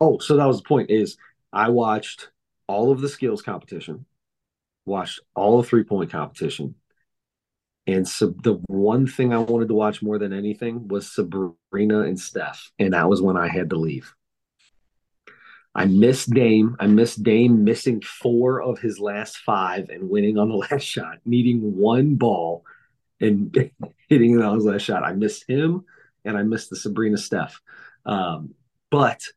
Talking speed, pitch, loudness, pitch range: 170 wpm, 110 Hz, -21 LUFS, 105-120 Hz